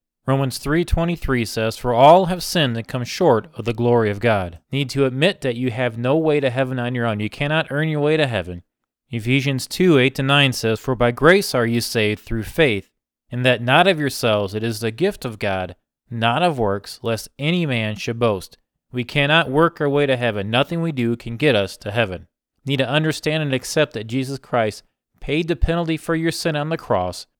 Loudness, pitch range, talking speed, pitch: -19 LUFS, 115-150 Hz, 210 wpm, 130 Hz